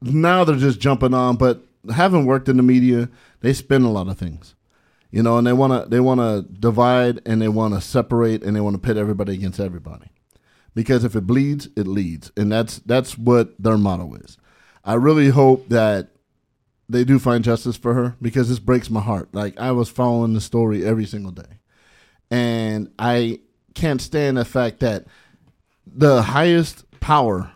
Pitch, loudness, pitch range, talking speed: 120 Hz, -18 LUFS, 105-130 Hz, 190 wpm